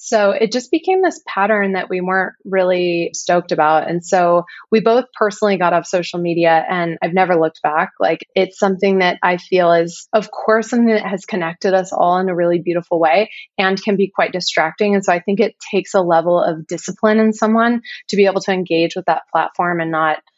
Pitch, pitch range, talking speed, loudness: 185 Hz, 175-210 Hz, 215 wpm, -16 LUFS